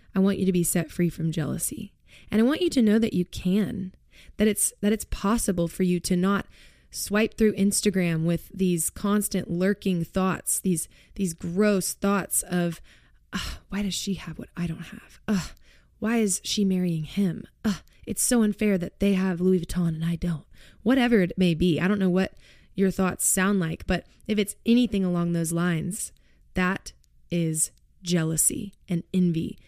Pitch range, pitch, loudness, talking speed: 175-205 Hz, 185 Hz, -25 LUFS, 180 wpm